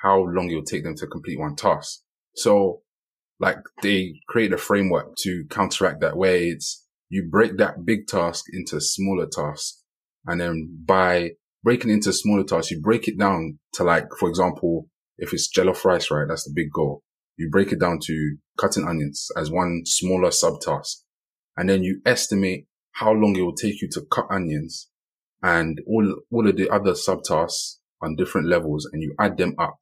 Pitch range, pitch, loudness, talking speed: 80-95 Hz, 90 Hz, -22 LUFS, 185 wpm